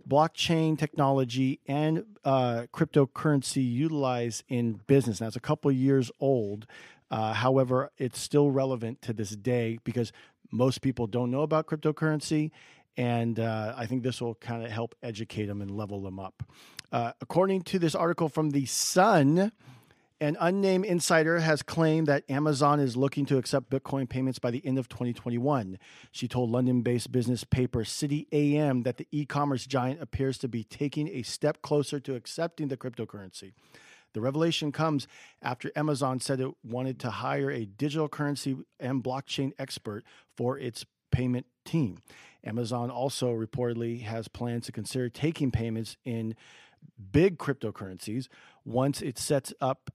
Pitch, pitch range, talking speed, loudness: 130 Hz, 120-145 Hz, 155 wpm, -29 LUFS